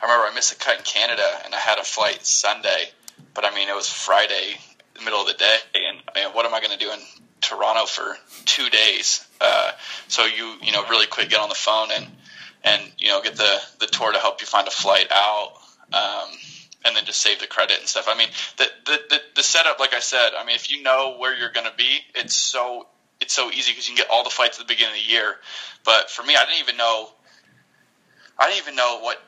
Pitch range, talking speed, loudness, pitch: 105-135 Hz, 255 wpm, -19 LUFS, 120 Hz